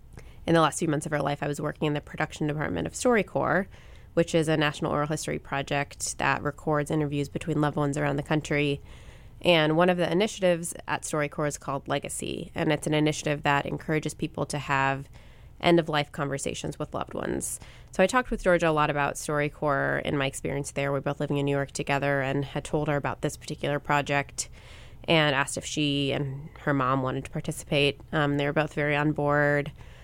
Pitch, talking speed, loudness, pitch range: 145 Hz, 205 wpm, -27 LUFS, 140-155 Hz